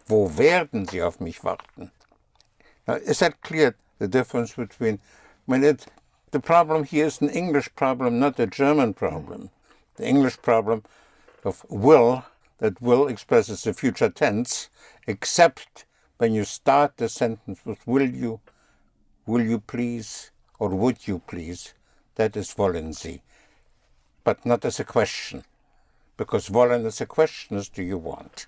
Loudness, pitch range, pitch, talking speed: -23 LUFS, 100-135 Hz, 115 Hz, 150 wpm